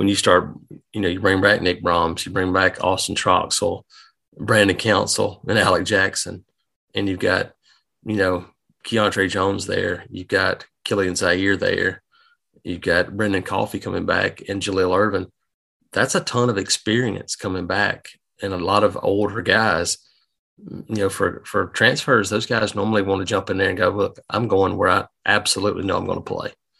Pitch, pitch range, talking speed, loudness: 100 Hz, 95-105 Hz, 180 wpm, -20 LUFS